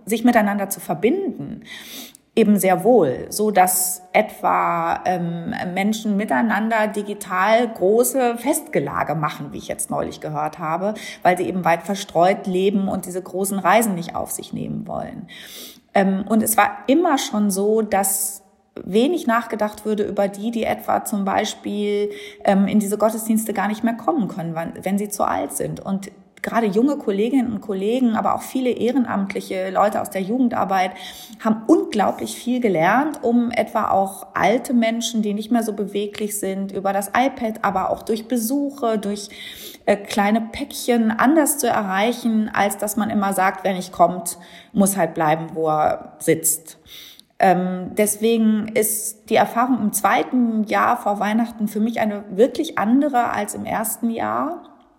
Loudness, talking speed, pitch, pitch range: -20 LUFS, 155 wpm, 210 Hz, 195-230 Hz